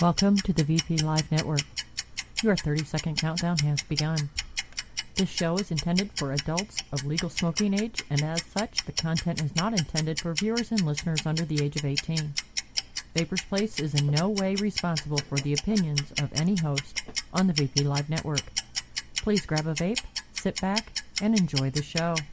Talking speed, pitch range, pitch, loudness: 180 wpm, 150-190 Hz, 160 Hz, -27 LUFS